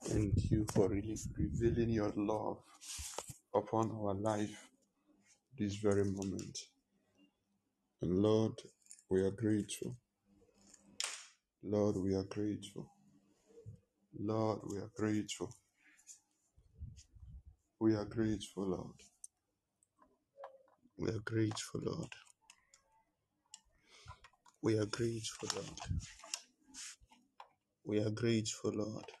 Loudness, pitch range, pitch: -38 LUFS, 100-110 Hz, 105 Hz